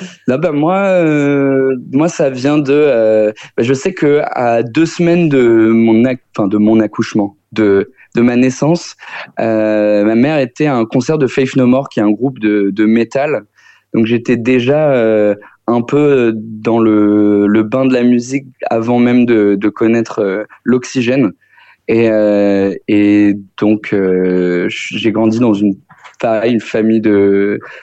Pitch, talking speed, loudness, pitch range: 115 Hz, 170 wpm, -12 LUFS, 105-130 Hz